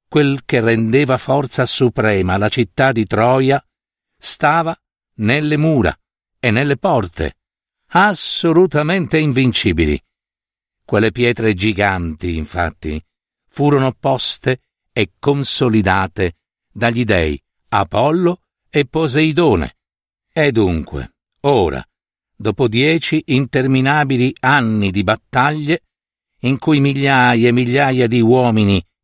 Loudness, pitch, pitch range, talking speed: -15 LUFS, 125 Hz, 105-140 Hz, 95 wpm